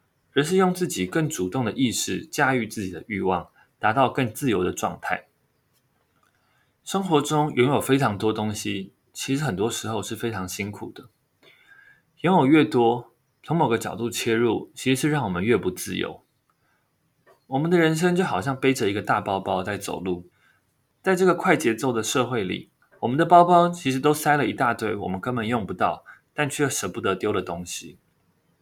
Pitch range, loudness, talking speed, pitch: 105-150 Hz, -23 LUFS, 265 characters per minute, 125 Hz